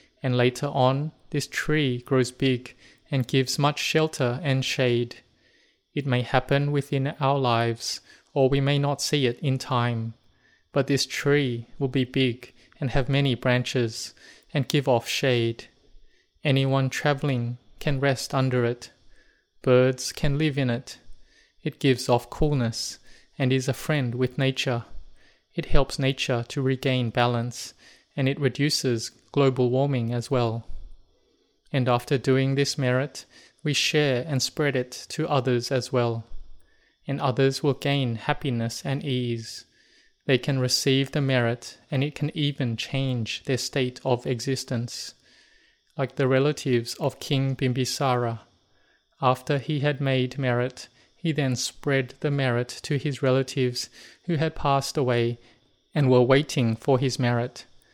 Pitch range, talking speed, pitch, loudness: 125-140 Hz, 145 wpm, 130 Hz, -25 LUFS